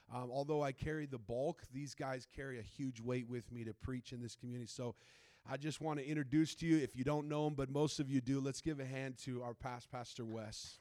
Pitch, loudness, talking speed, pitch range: 130 Hz, -42 LUFS, 255 wpm, 120-145 Hz